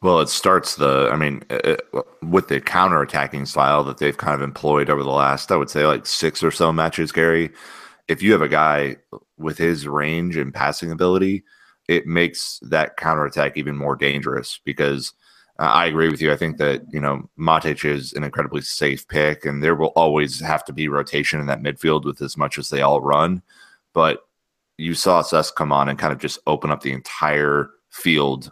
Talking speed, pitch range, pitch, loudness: 200 wpm, 70-80 Hz, 75 Hz, -20 LUFS